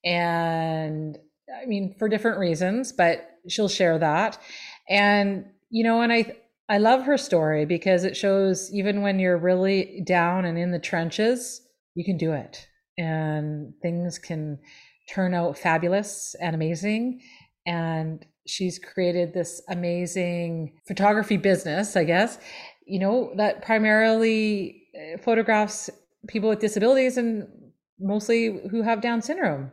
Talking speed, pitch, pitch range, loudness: 135 wpm, 190 Hz, 170-220 Hz, -24 LUFS